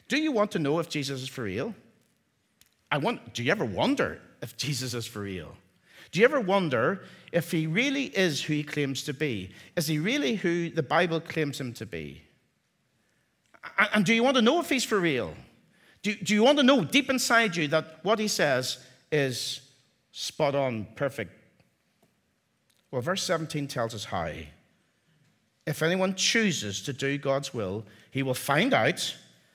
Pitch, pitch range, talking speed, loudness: 150 Hz, 125-195 Hz, 180 wpm, -27 LUFS